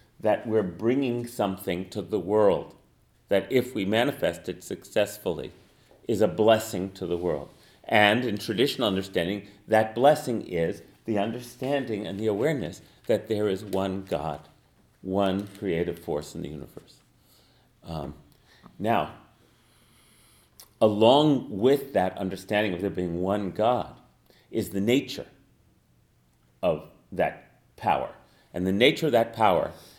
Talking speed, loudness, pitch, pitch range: 130 wpm, -26 LUFS, 105 Hz, 95-115 Hz